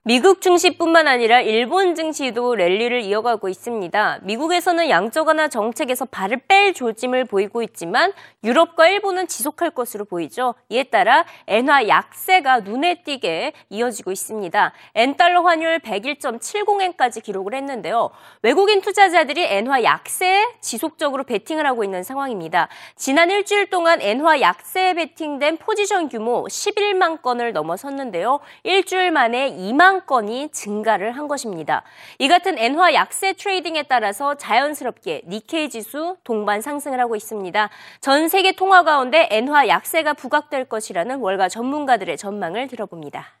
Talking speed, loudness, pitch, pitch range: 340 characters per minute, -18 LUFS, 280 Hz, 230-345 Hz